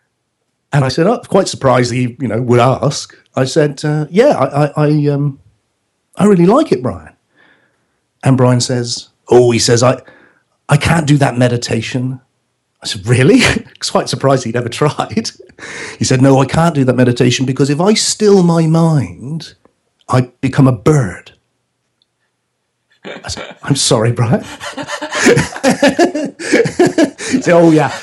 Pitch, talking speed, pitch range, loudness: 135 Hz, 150 wpm, 125-160 Hz, -12 LUFS